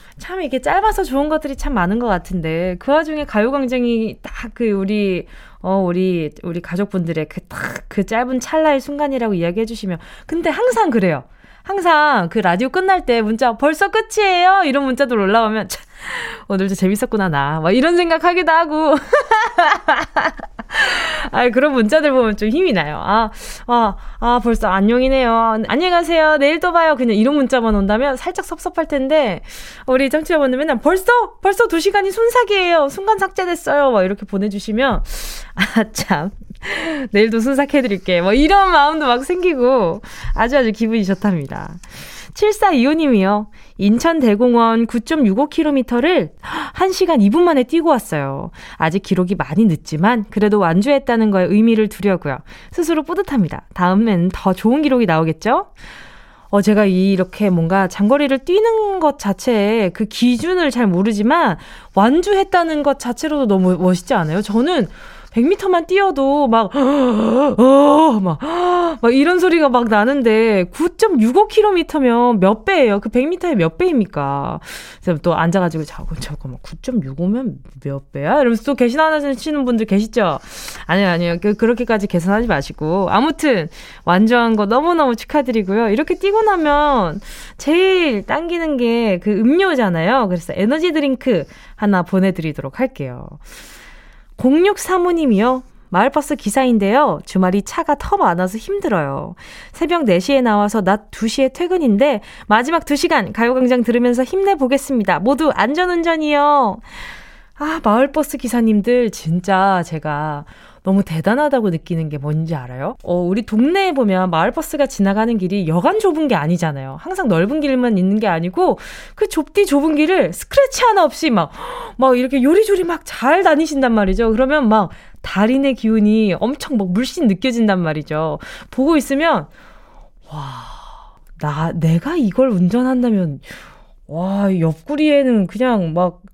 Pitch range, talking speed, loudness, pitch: 195-300 Hz, 320 characters per minute, -16 LUFS, 240 Hz